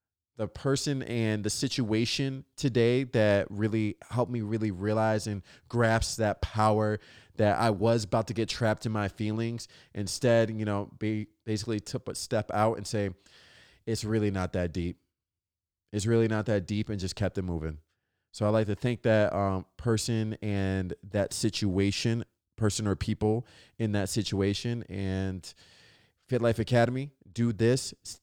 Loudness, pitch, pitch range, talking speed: -29 LUFS, 110 Hz, 100-115 Hz, 160 wpm